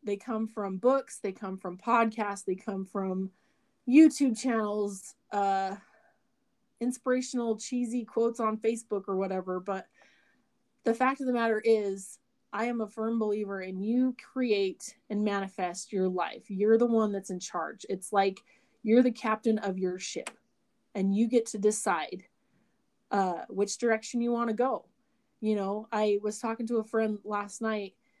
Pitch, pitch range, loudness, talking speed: 220 Hz, 195-240 Hz, -30 LUFS, 160 wpm